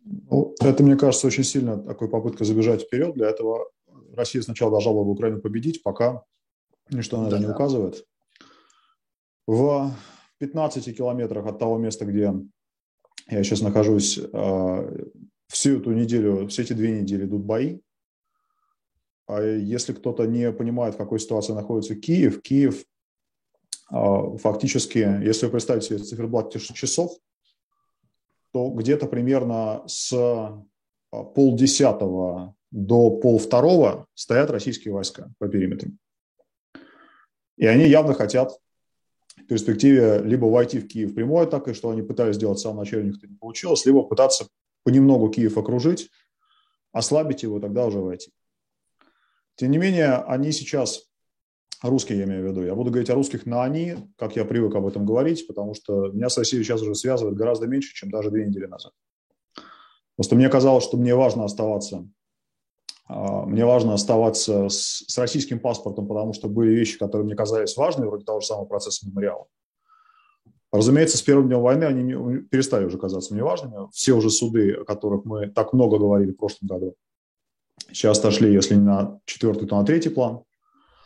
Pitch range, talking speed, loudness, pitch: 105-135 Hz, 155 wpm, -22 LUFS, 115 Hz